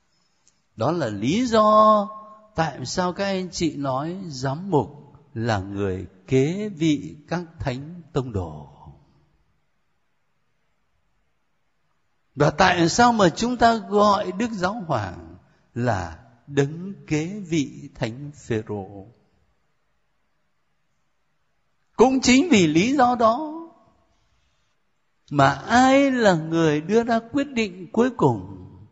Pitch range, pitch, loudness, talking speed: 130-215 Hz, 165 Hz, -21 LUFS, 110 wpm